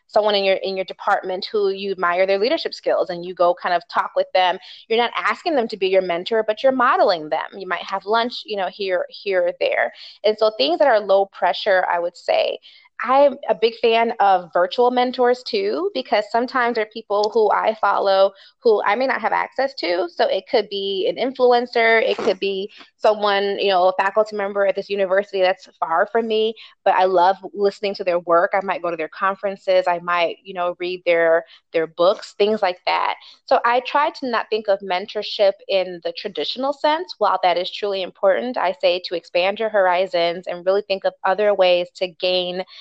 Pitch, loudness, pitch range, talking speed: 195 Hz, -20 LUFS, 185-225 Hz, 215 wpm